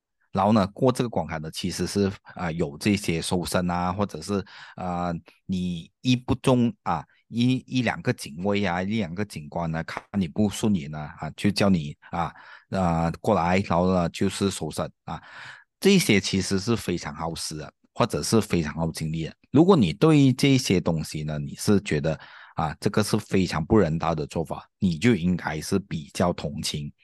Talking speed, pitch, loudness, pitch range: 260 characters per minute, 95 Hz, -25 LUFS, 85-115 Hz